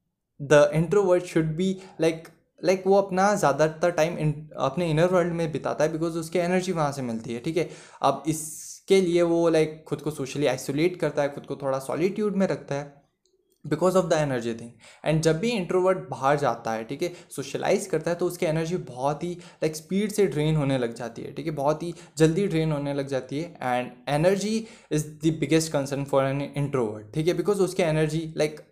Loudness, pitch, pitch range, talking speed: -25 LUFS, 160 Hz, 140-175 Hz, 205 wpm